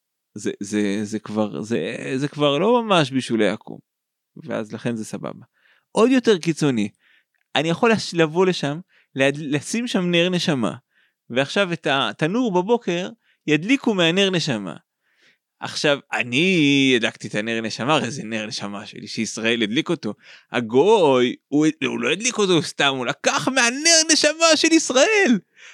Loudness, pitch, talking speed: -20 LUFS, 155 Hz, 140 wpm